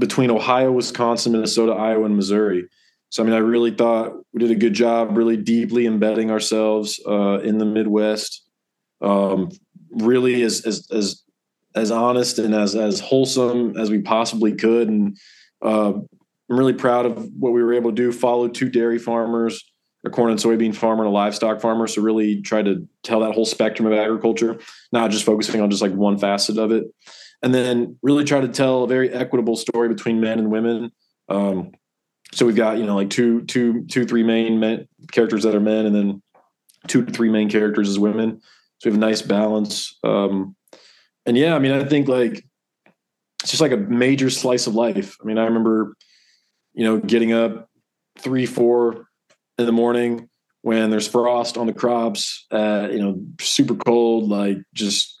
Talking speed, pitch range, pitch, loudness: 190 wpm, 110-120 Hz, 115 Hz, -19 LUFS